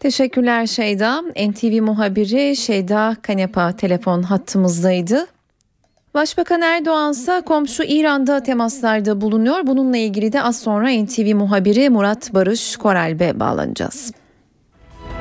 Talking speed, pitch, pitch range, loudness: 105 wpm, 220 Hz, 200-270 Hz, -17 LUFS